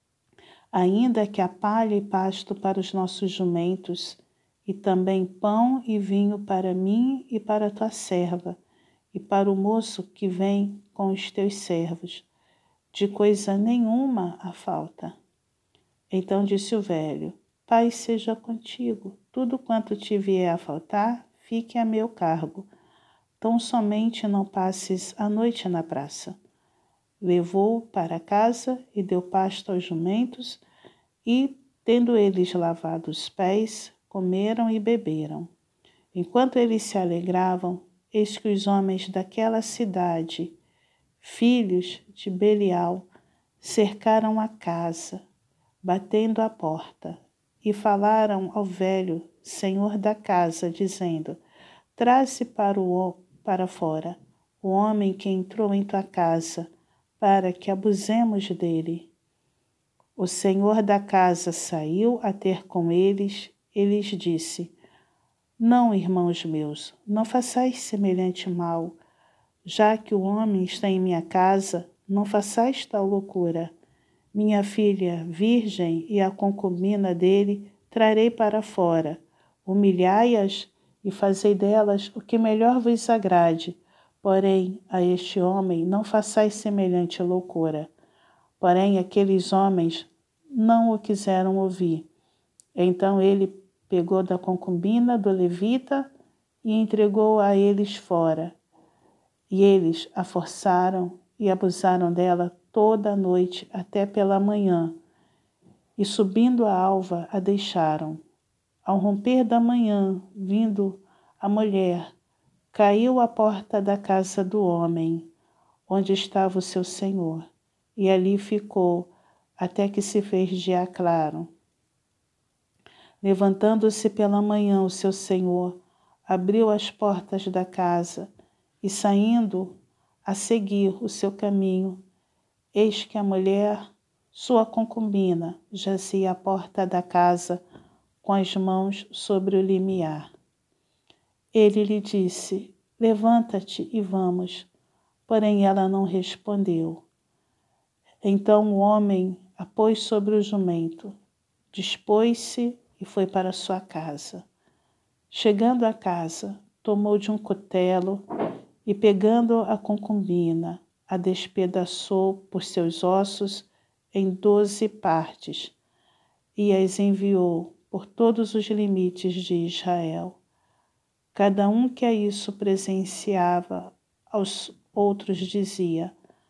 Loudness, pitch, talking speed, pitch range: -24 LUFS, 195 Hz, 115 wpm, 180-210 Hz